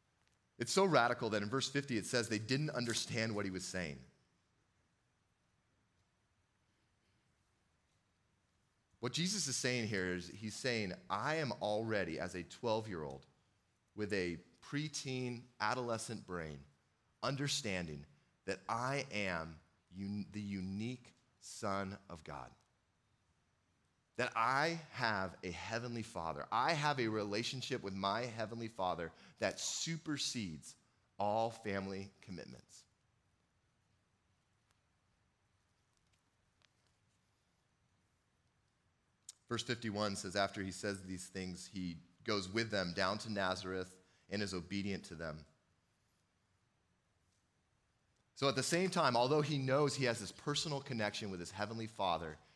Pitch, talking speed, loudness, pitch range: 105 Hz, 120 wpm, -39 LUFS, 95-120 Hz